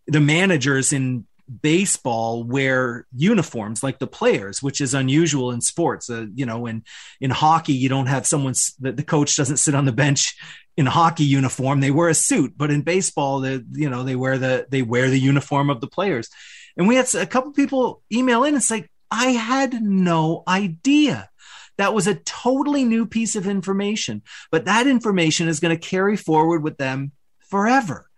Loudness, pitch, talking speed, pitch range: -20 LUFS, 150 Hz, 190 wpm, 135-195 Hz